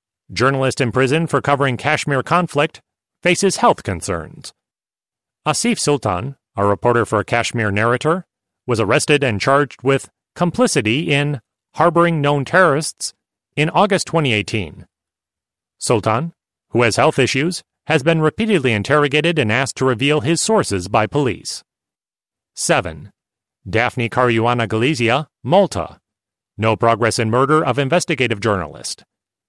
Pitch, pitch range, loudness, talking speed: 135 Hz, 115-155 Hz, -17 LUFS, 120 wpm